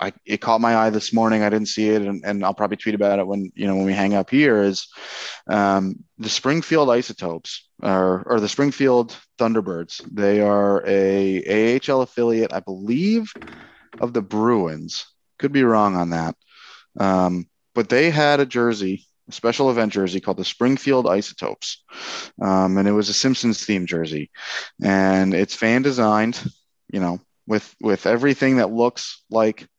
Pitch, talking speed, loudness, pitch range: 105 Hz, 170 wpm, -20 LUFS, 95-120 Hz